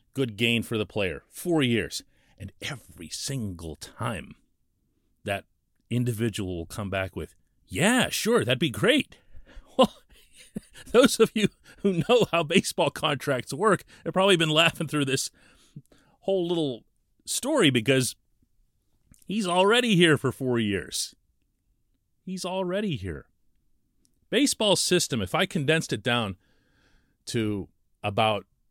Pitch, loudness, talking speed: 130 Hz, -25 LUFS, 125 wpm